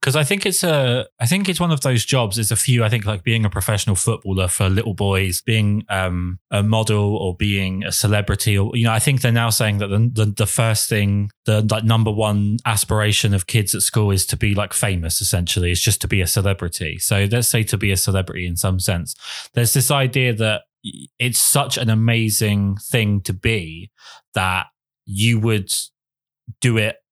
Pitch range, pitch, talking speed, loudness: 100-115 Hz, 110 Hz, 210 wpm, -18 LUFS